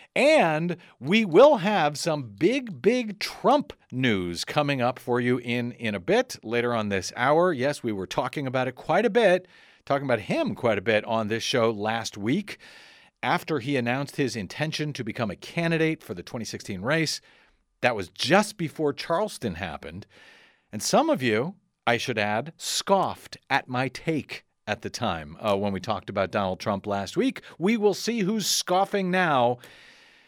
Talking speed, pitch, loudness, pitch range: 175 wpm, 145 Hz, -25 LUFS, 120-185 Hz